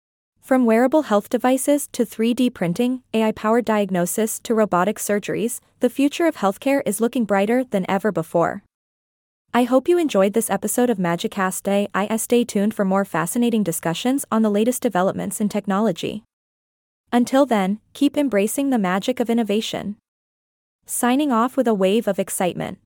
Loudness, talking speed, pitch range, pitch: -20 LUFS, 155 wpm, 195-245 Hz, 220 Hz